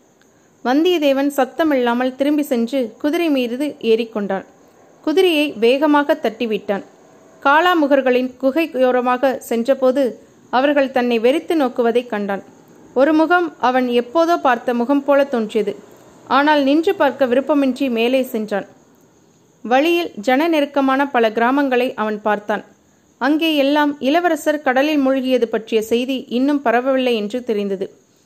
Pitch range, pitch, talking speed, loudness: 235-290 Hz, 260 Hz, 110 wpm, -17 LUFS